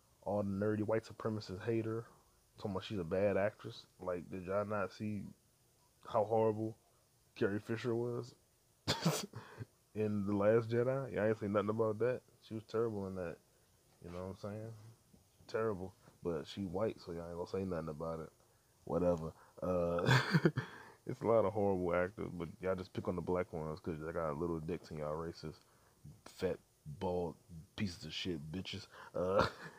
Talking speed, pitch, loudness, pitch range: 175 wpm, 100 Hz, -38 LUFS, 90-110 Hz